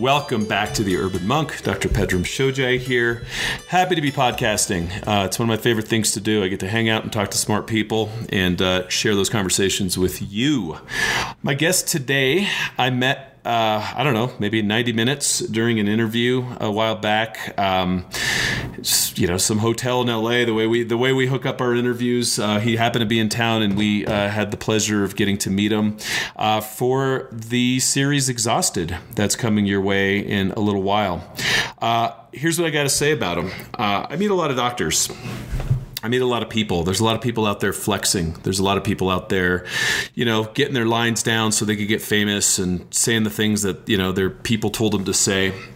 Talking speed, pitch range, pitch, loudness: 220 wpm, 100-125 Hz, 110 Hz, -20 LUFS